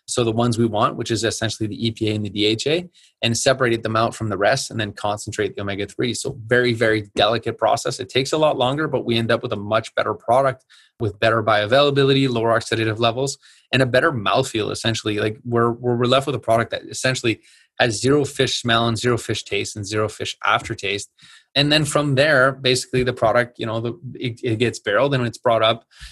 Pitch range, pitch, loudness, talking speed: 110-130 Hz, 115 Hz, -20 LUFS, 215 wpm